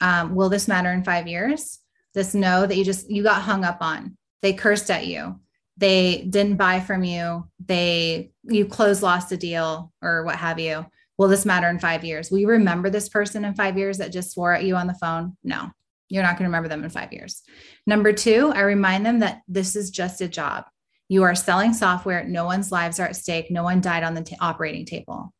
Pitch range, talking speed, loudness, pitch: 170-200 Hz, 230 wpm, -22 LUFS, 185 Hz